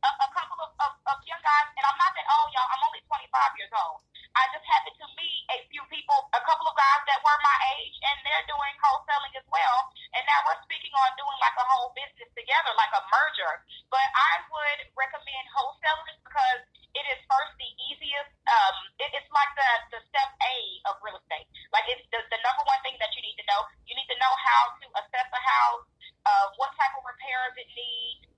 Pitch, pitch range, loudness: 280 Hz, 255-330 Hz, -26 LUFS